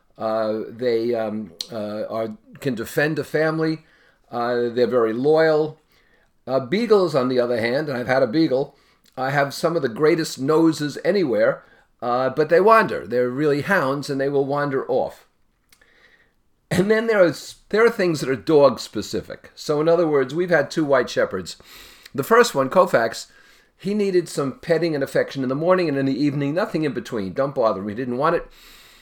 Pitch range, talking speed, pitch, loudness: 125-165 Hz, 190 wpm, 145 Hz, -21 LUFS